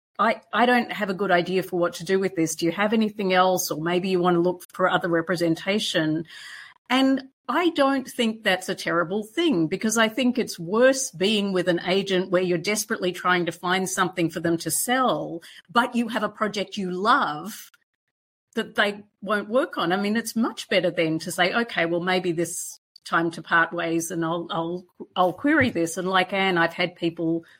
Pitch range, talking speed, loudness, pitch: 175-220 Hz, 205 wpm, -23 LUFS, 185 Hz